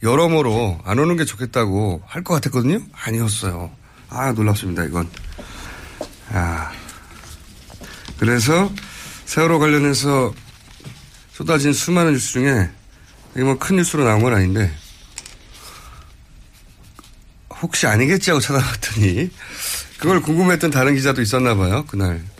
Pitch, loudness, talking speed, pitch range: 120 Hz, -18 LUFS, 255 characters per minute, 95-145 Hz